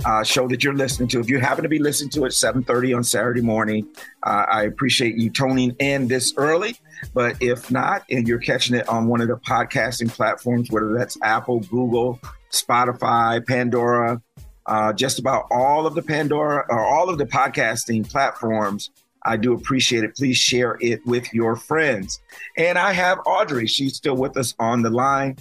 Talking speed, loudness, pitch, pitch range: 185 wpm, -20 LUFS, 125 Hz, 115-135 Hz